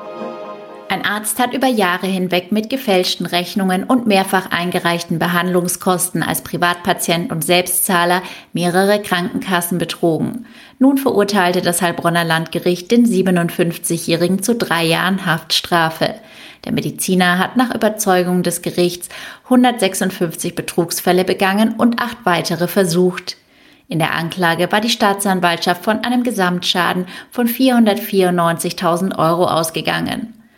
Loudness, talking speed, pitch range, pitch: -16 LUFS, 110 wpm, 175-205 Hz, 180 Hz